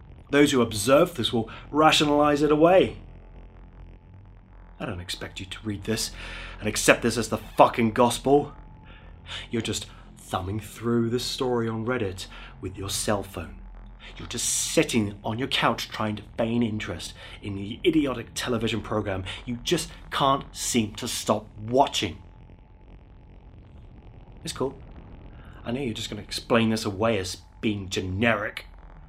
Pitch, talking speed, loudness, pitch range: 105 Hz, 145 wpm, -25 LUFS, 95-120 Hz